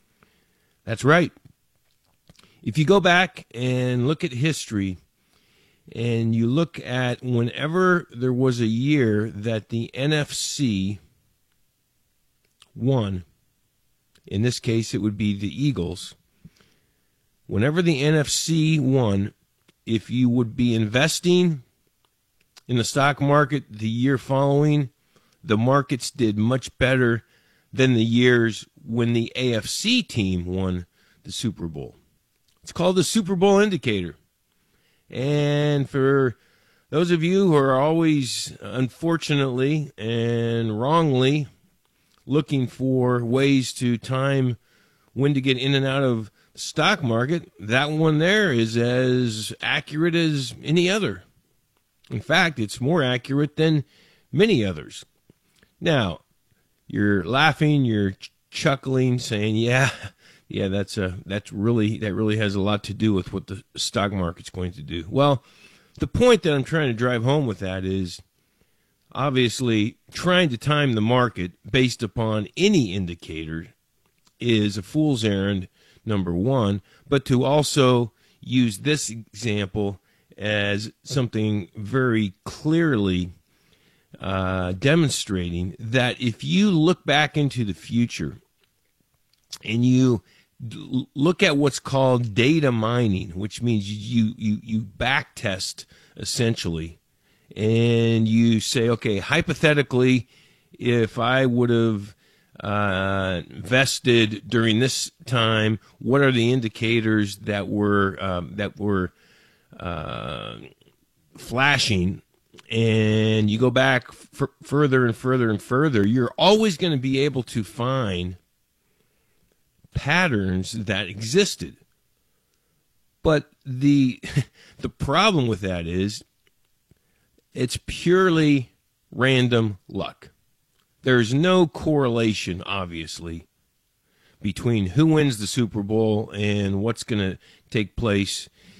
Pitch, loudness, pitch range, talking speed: 120 Hz, -22 LUFS, 105-140 Hz, 120 wpm